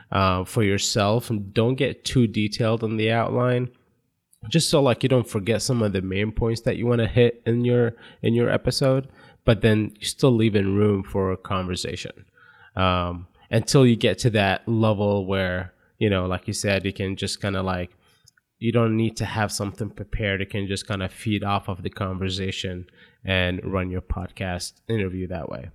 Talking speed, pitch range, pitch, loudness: 200 wpm, 95-115 Hz, 105 Hz, -23 LUFS